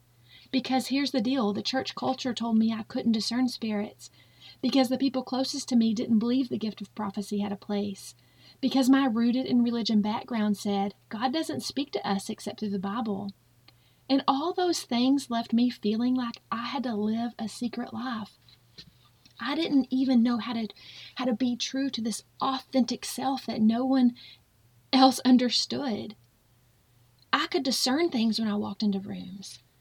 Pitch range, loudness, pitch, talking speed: 200-260 Hz, -28 LUFS, 230 Hz, 175 wpm